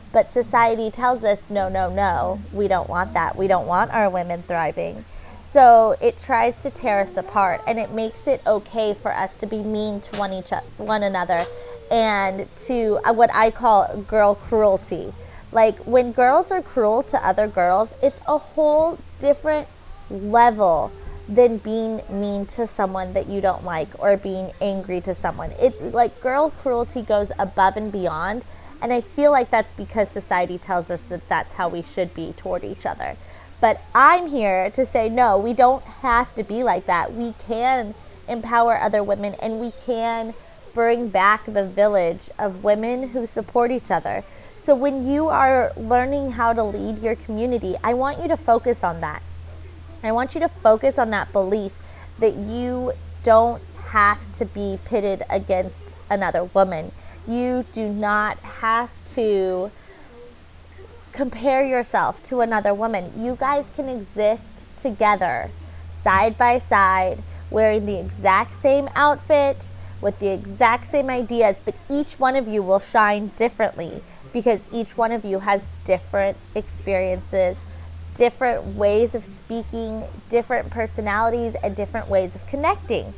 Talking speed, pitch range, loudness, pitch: 160 wpm, 195-245 Hz, -21 LUFS, 220 Hz